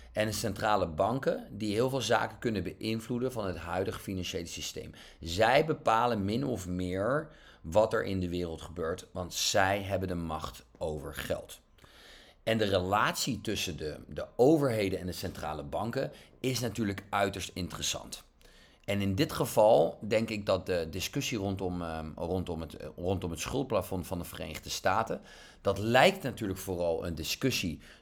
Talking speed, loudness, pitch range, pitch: 155 wpm, -31 LUFS, 85-110 Hz, 95 Hz